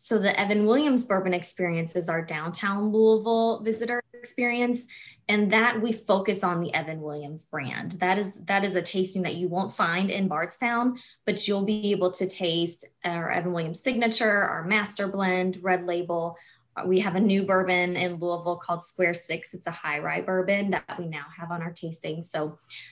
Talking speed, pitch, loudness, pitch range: 185 wpm, 185 Hz, -26 LUFS, 170-210 Hz